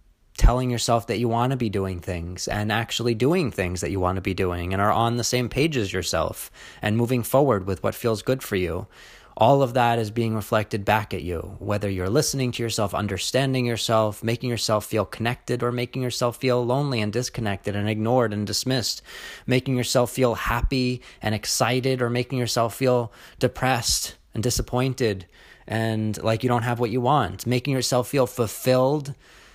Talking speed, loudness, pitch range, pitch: 185 wpm, -24 LUFS, 105-125 Hz, 115 Hz